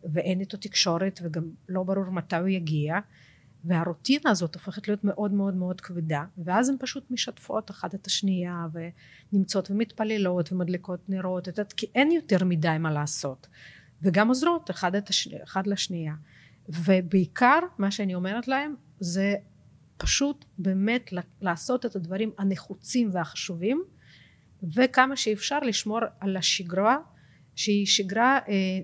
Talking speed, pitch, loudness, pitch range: 125 wpm, 190 Hz, -26 LUFS, 175-215 Hz